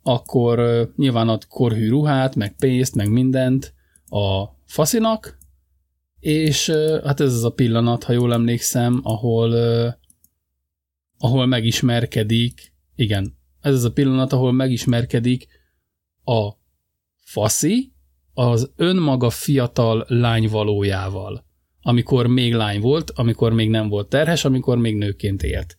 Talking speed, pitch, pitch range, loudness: 120 wpm, 120 Hz, 100-130 Hz, -19 LUFS